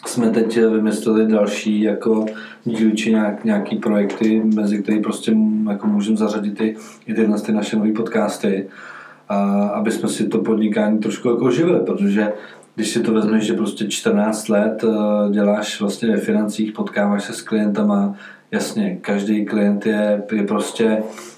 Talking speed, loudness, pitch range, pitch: 155 wpm, -19 LUFS, 105-115 Hz, 110 Hz